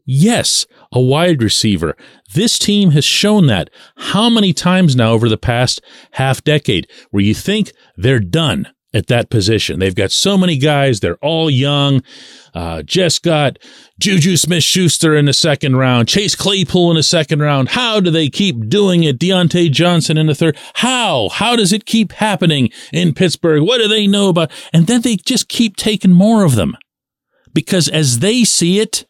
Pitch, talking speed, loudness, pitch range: 165 Hz, 180 wpm, -13 LUFS, 135-195 Hz